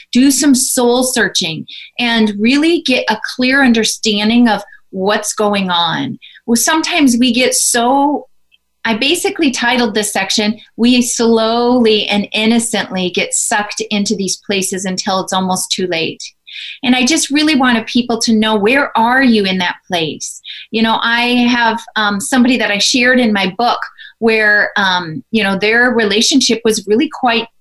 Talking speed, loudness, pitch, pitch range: 160 wpm, -12 LUFS, 230 Hz, 210-250 Hz